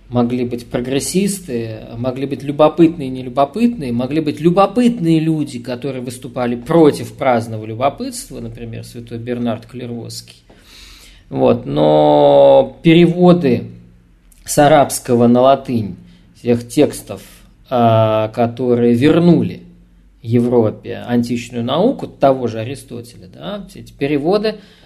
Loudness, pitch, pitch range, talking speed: -15 LUFS, 120 Hz, 110-145 Hz, 100 wpm